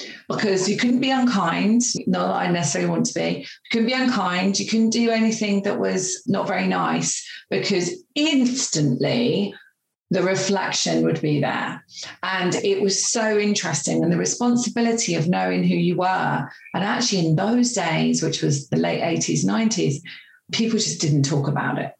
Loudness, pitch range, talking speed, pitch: -21 LUFS, 165-230 Hz, 170 wpm, 195 Hz